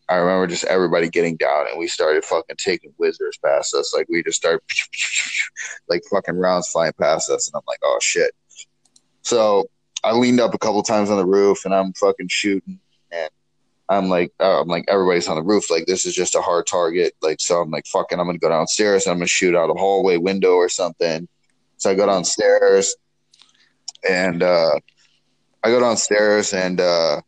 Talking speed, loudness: 200 wpm, -19 LUFS